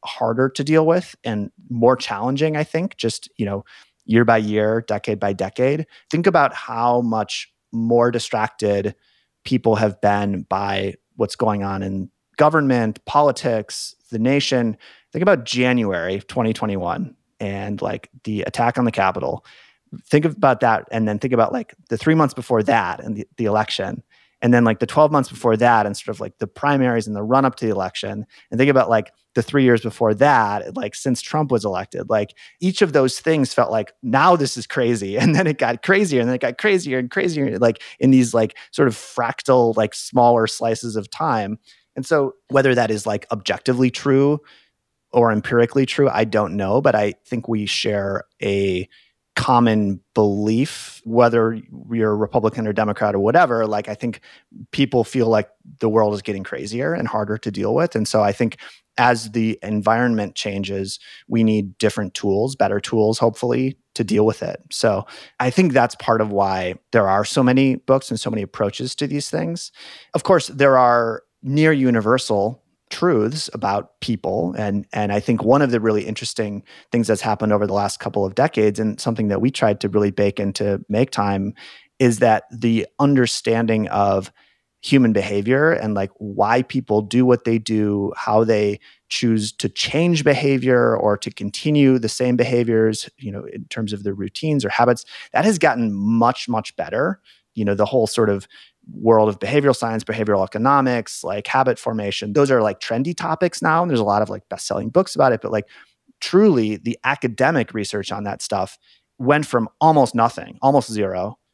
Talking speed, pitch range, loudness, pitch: 185 wpm, 105-130 Hz, -19 LUFS, 115 Hz